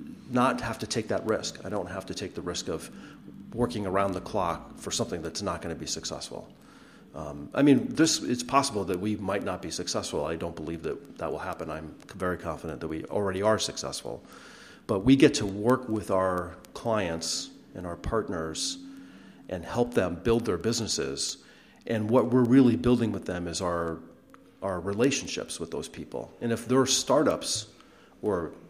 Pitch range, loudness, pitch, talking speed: 85-120 Hz, -28 LUFS, 100 Hz, 185 wpm